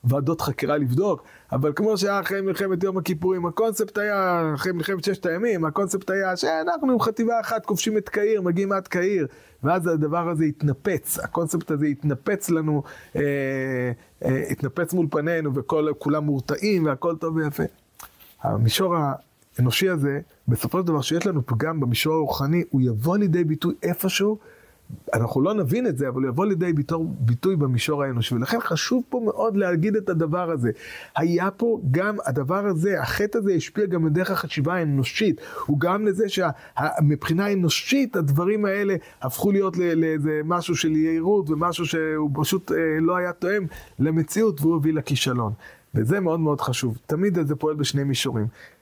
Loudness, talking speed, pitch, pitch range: -23 LUFS, 155 wpm, 165 Hz, 145-190 Hz